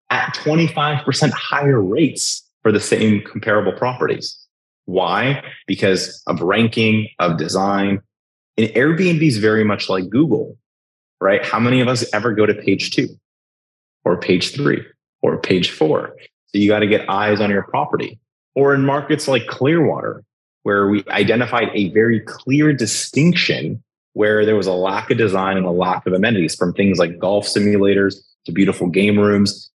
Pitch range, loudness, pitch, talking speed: 100-125 Hz, -17 LUFS, 105 Hz, 160 wpm